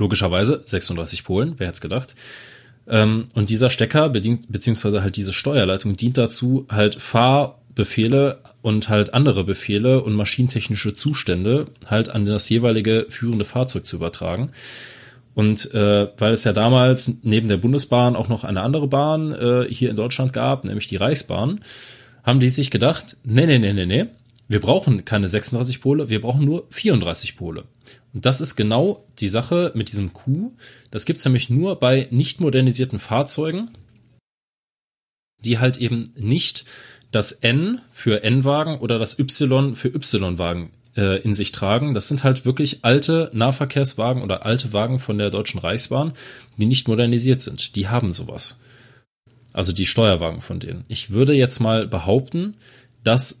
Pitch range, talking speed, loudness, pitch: 105-135 Hz, 155 wpm, -19 LUFS, 120 Hz